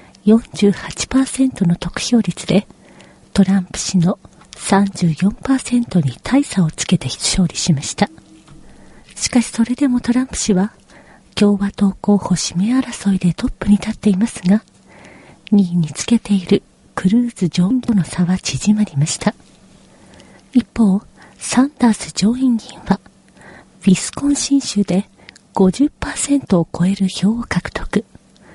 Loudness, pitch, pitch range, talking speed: -17 LUFS, 200 Hz, 180-235 Hz, 235 characters per minute